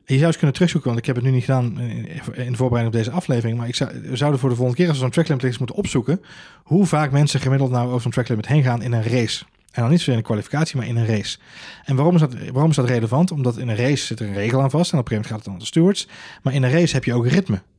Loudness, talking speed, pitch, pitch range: -20 LUFS, 315 wpm, 130 Hz, 120-150 Hz